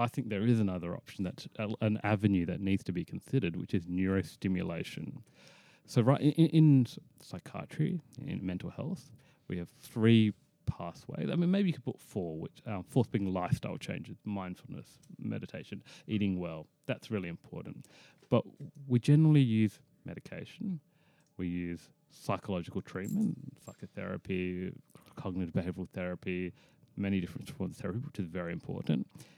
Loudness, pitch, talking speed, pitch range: -33 LUFS, 110 Hz, 145 wpm, 95-145 Hz